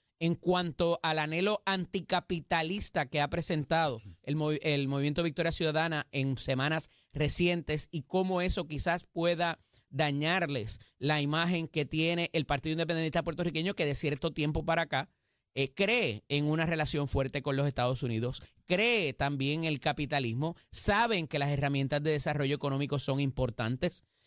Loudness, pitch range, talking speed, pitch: -31 LUFS, 140-170 Hz, 150 wpm, 155 Hz